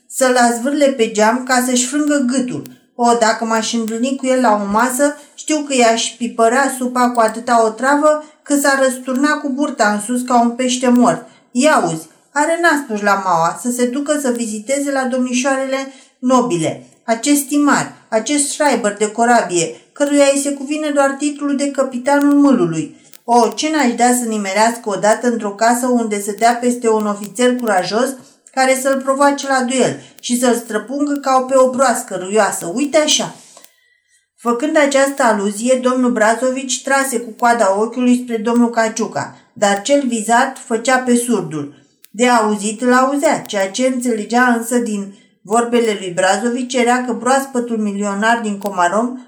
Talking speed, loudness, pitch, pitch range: 165 wpm, -15 LUFS, 245 Hz, 225-270 Hz